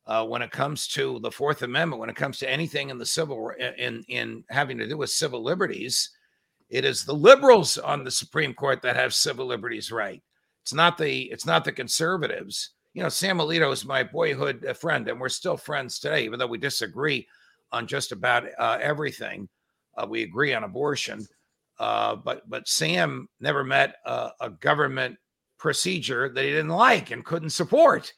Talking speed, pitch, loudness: 185 wpm, 155 Hz, -24 LUFS